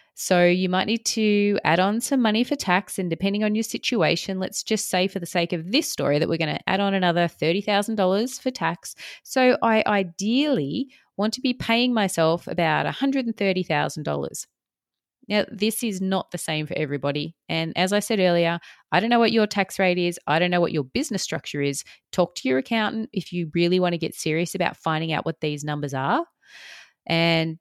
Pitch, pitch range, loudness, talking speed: 190 Hz, 165-220 Hz, -23 LUFS, 200 wpm